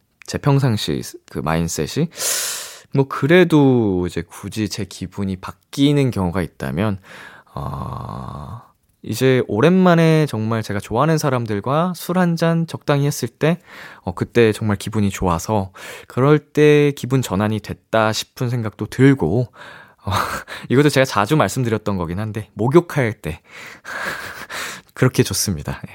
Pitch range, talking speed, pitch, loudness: 100-140 Hz, 265 characters per minute, 115 Hz, -19 LUFS